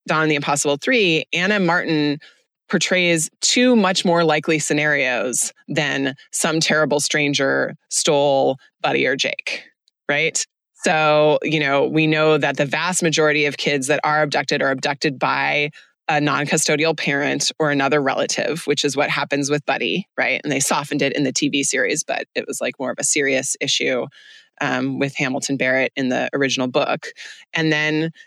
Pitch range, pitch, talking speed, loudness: 140-160 Hz, 150 Hz, 165 wpm, -19 LUFS